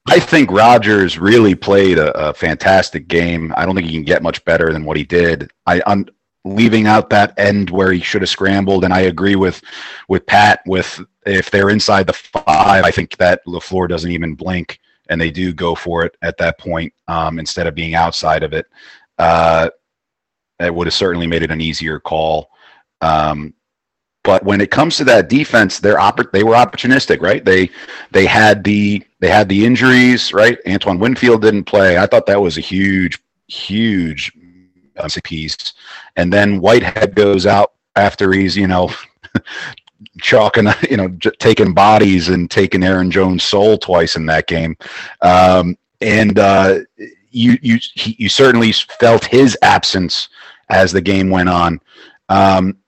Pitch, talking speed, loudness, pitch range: 95 Hz, 170 wpm, -12 LUFS, 85-100 Hz